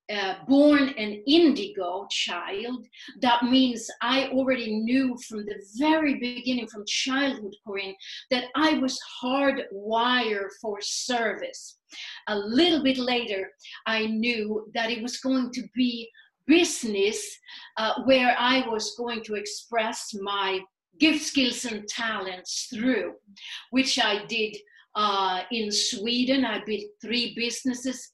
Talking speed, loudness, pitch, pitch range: 125 wpm, -25 LUFS, 240 Hz, 215-265 Hz